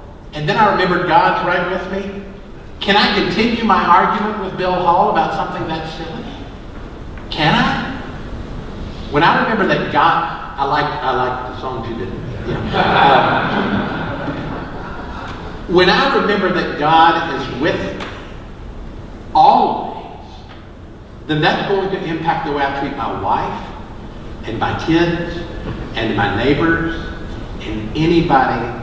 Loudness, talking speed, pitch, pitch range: -16 LUFS, 135 wpm, 160 Hz, 120-180 Hz